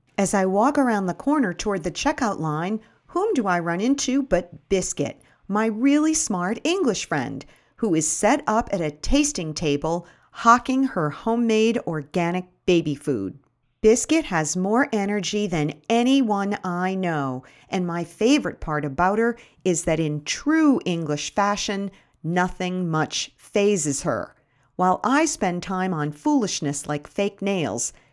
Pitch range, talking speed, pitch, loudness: 160-230 Hz, 145 wpm, 185 Hz, -23 LUFS